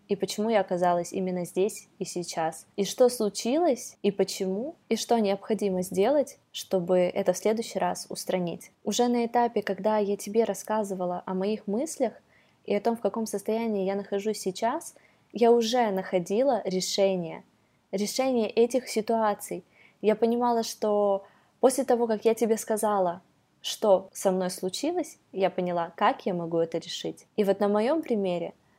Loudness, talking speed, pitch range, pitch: -27 LUFS, 155 wpm, 190-230 Hz, 205 Hz